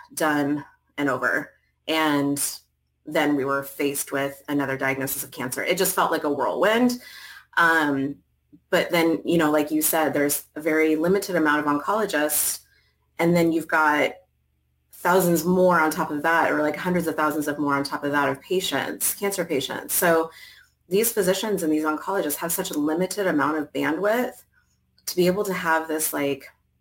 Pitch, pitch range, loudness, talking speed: 155 Hz, 140-175 Hz, -23 LUFS, 175 wpm